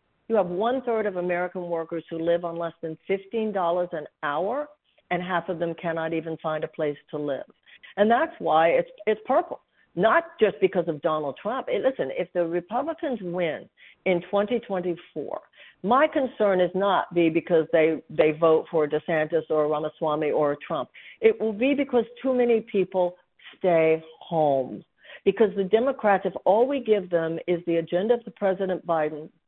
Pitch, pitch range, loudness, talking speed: 180 Hz, 165-220 Hz, -25 LUFS, 175 wpm